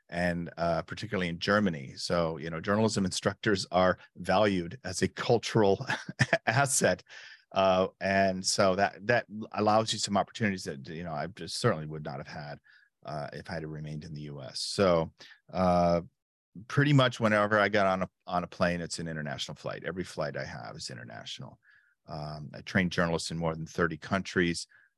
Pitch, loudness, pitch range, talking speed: 90 Hz, -29 LUFS, 80-105 Hz, 180 wpm